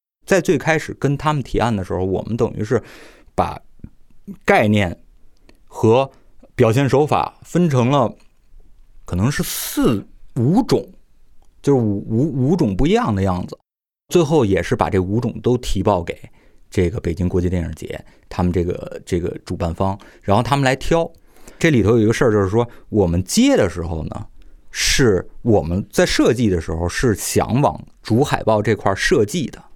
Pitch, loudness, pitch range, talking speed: 110 Hz, -18 LUFS, 95-135 Hz, 240 characters per minute